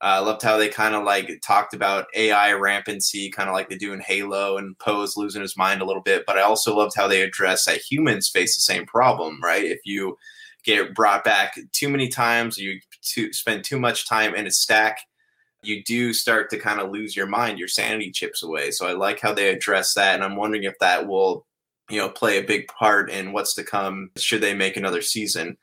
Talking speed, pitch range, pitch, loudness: 230 wpm, 95-110 Hz, 105 Hz, -21 LUFS